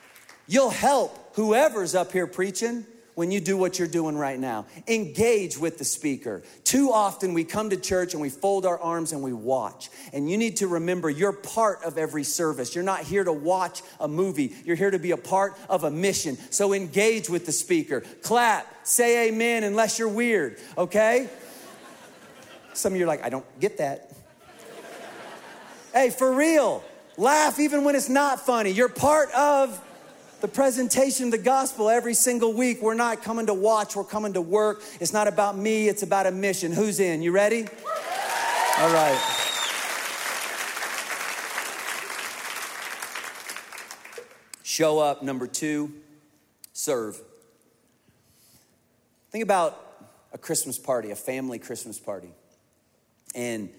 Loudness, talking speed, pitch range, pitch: -24 LUFS, 155 wpm, 170-240 Hz, 205 Hz